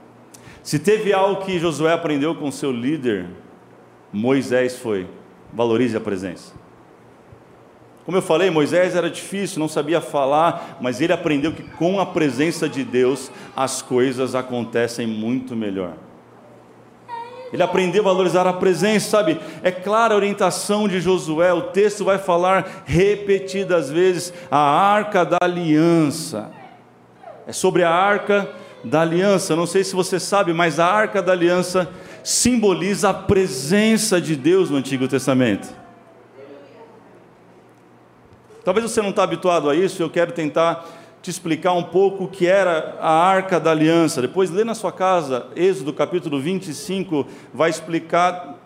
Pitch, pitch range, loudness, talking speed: 170 Hz, 145-190 Hz, -19 LUFS, 140 wpm